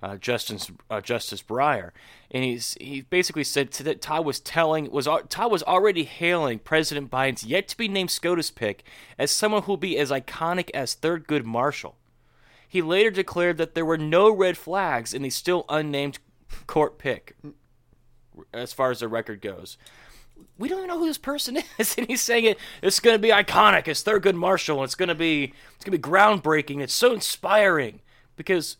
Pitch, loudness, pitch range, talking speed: 165 Hz, -23 LUFS, 135-195 Hz, 195 wpm